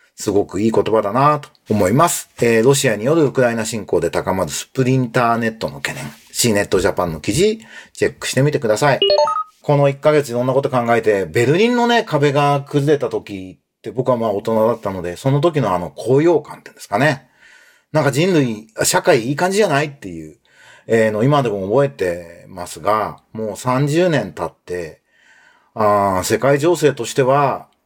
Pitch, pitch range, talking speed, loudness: 135 Hz, 110-150 Hz, 365 characters per minute, -17 LUFS